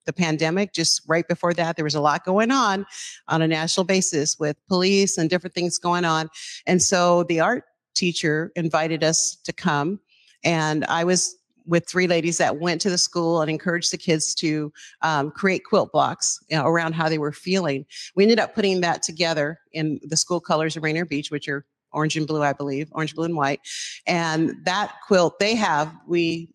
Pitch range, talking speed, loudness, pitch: 155-180 Hz, 200 wpm, -22 LUFS, 165 Hz